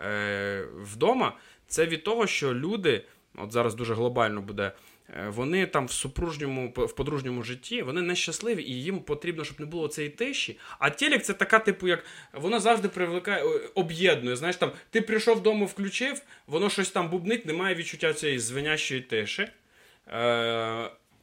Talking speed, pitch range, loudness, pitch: 155 wpm, 125-200 Hz, -28 LUFS, 160 Hz